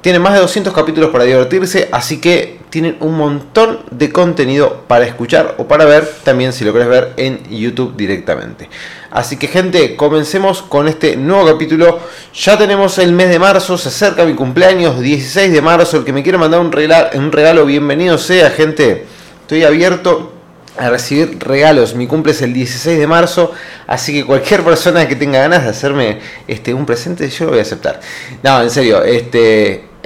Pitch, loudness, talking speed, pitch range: 155 Hz, -11 LUFS, 185 wpm, 135-175 Hz